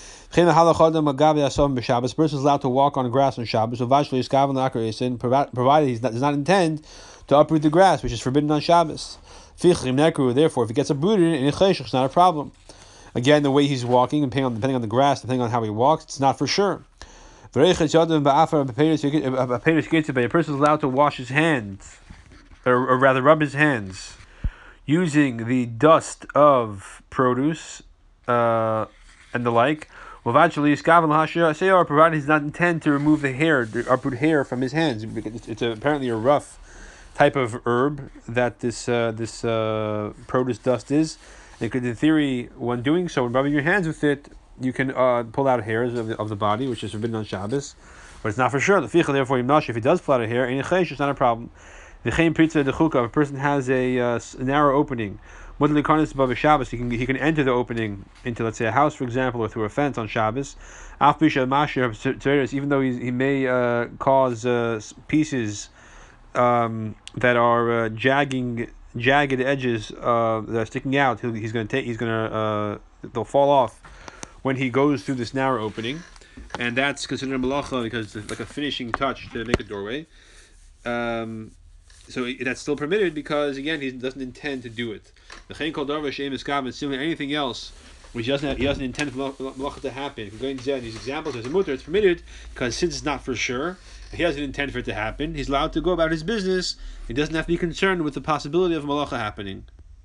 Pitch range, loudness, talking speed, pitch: 120-150 Hz, -22 LUFS, 190 wpm, 135 Hz